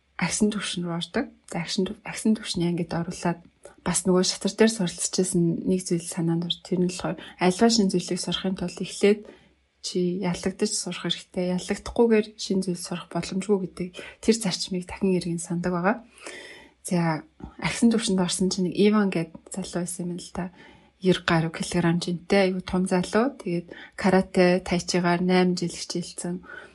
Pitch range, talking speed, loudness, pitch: 175-195 Hz, 160 wpm, -25 LUFS, 185 Hz